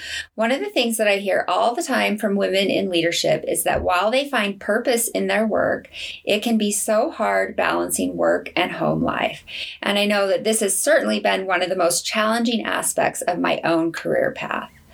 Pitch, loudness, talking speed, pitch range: 205 Hz, -20 LUFS, 210 wpm, 185-225 Hz